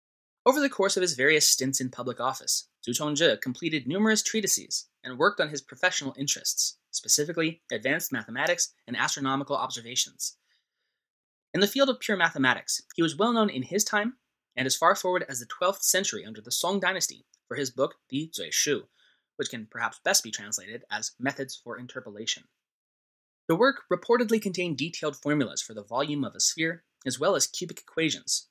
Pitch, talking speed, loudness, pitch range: 160 Hz, 180 wpm, -27 LUFS, 135-195 Hz